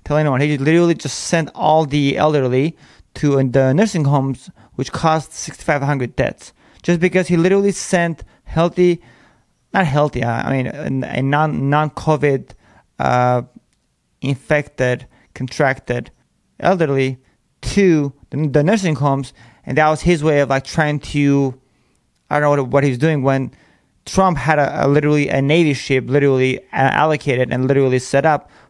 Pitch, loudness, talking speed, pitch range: 145 Hz, -17 LUFS, 140 wpm, 130-155 Hz